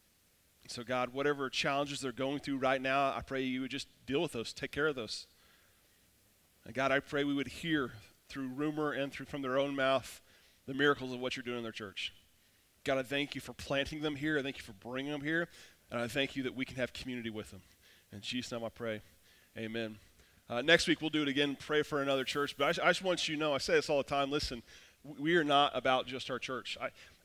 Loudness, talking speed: -35 LUFS, 245 wpm